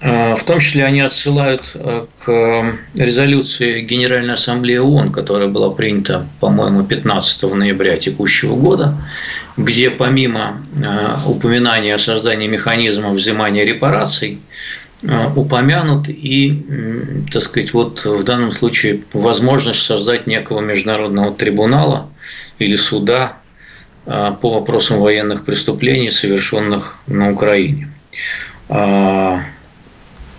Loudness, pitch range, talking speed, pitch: -14 LUFS, 105-130 Hz, 95 wpm, 115 Hz